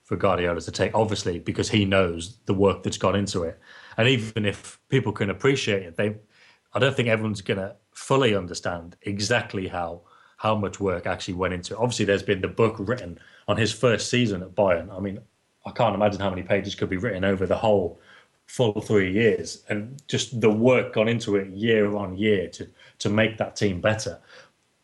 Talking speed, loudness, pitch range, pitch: 205 wpm, -24 LUFS, 95-110 Hz, 105 Hz